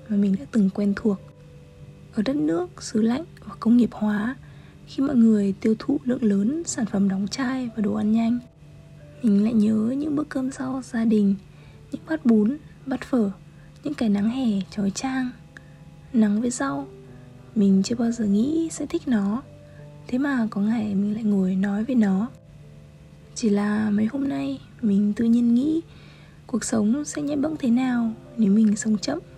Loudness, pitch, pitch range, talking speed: -23 LUFS, 225 Hz, 205-260 Hz, 185 wpm